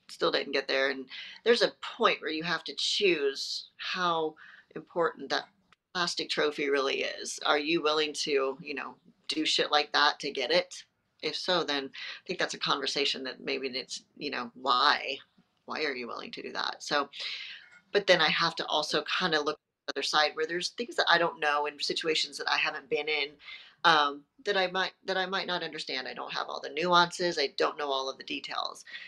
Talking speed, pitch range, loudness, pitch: 215 wpm, 145-180 Hz, -29 LUFS, 155 Hz